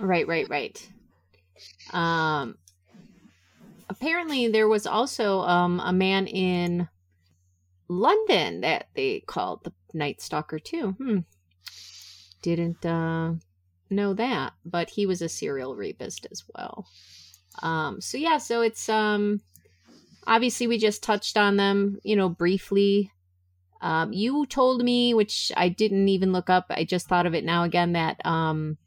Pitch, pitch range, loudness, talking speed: 180 Hz, 155-215 Hz, -25 LUFS, 140 wpm